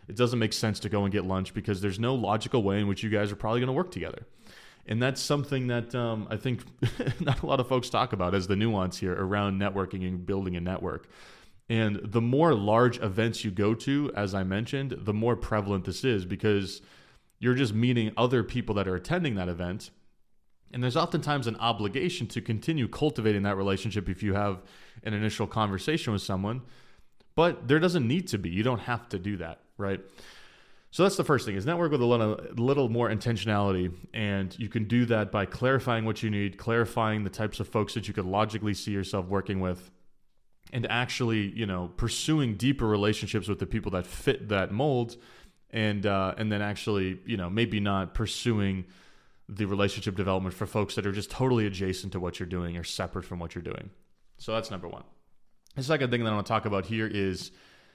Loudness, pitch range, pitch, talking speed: -29 LUFS, 100-120 Hz, 110 Hz, 210 wpm